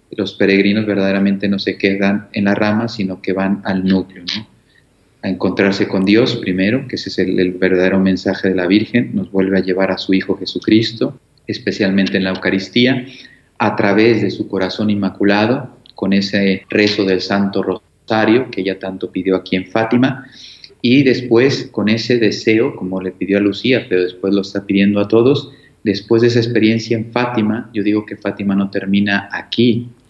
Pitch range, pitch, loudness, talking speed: 95-115 Hz, 100 Hz, -16 LUFS, 180 wpm